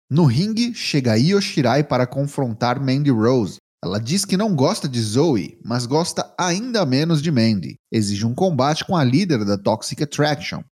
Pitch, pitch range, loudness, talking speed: 145 Hz, 120-180 Hz, -19 LUFS, 165 wpm